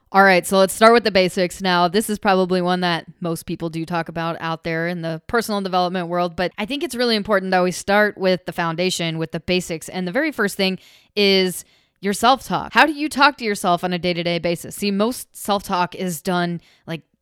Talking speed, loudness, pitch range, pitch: 240 wpm, -19 LUFS, 175-205 Hz, 185 Hz